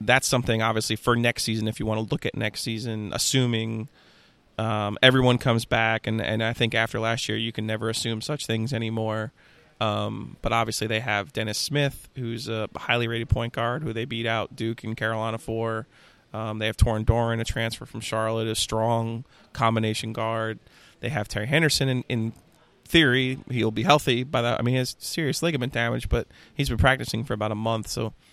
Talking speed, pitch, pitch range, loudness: 200 wpm, 115 Hz, 110-120 Hz, -25 LUFS